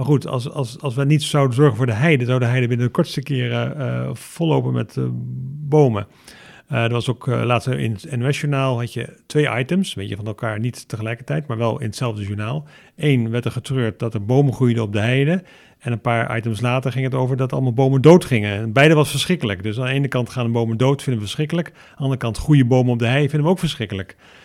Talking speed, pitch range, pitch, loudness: 245 wpm, 115-140 Hz, 125 Hz, -19 LUFS